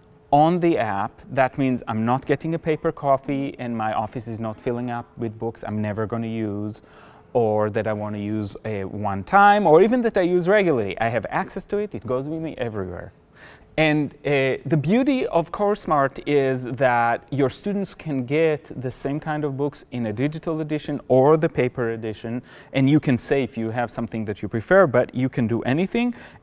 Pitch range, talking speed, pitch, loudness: 115-155 Hz, 205 wpm, 130 Hz, -22 LUFS